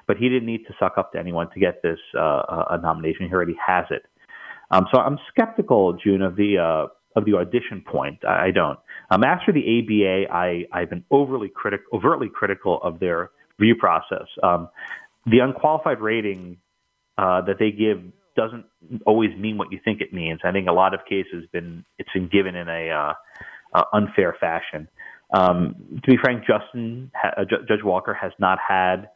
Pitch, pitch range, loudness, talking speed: 100 Hz, 90-110 Hz, -22 LUFS, 190 wpm